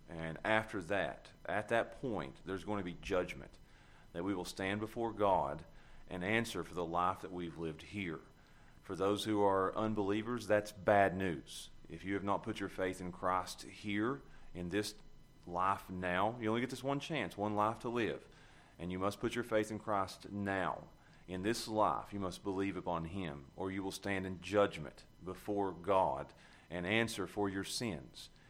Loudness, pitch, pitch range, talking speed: -38 LUFS, 100 Hz, 90-105 Hz, 185 wpm